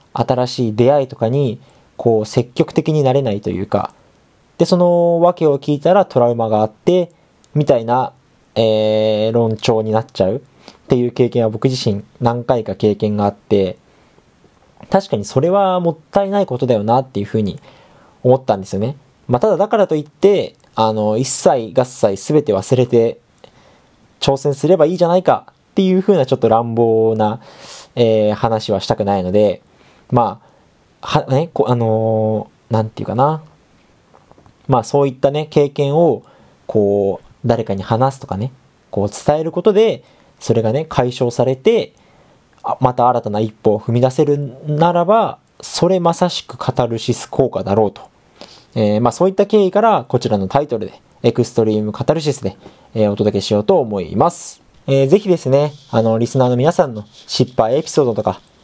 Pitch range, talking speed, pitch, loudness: 110-150 Hz, 315 characters per minute, 125 Hz, -16 LUFS